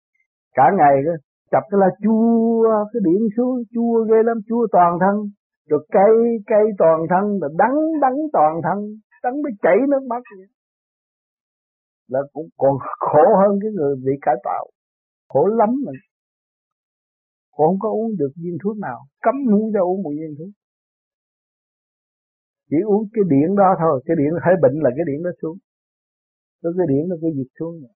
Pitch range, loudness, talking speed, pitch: 155-225 Hz, -18 LUFS, 175 wpm, 195 Hz